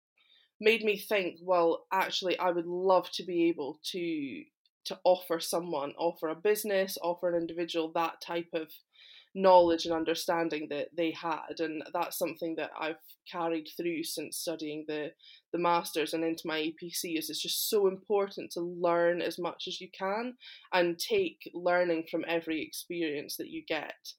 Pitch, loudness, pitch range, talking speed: 170 Hz, -31 LUFS, 165-190 Hz, 165 wpm